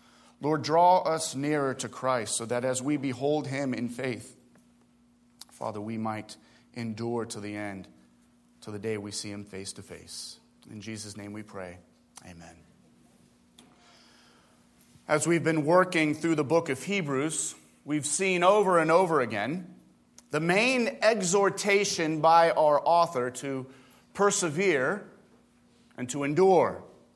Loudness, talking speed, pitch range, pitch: -27 LUFS, 135 wpm, 105-160 Hz, 130 Hz